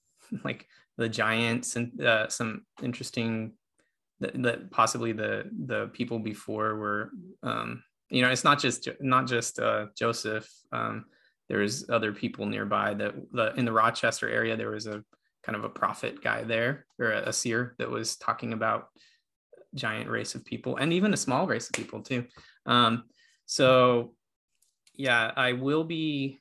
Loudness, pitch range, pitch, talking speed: -28 LUFS, 110-125 Hz, 120 Hz, 160 wpm